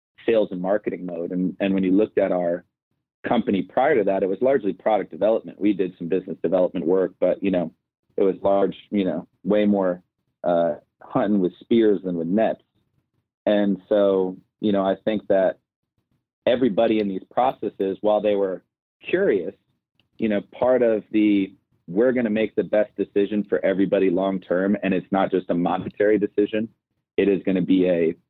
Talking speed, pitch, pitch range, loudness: 185 wpm, 100 Hz, 95-105 Hz, -22 LUFS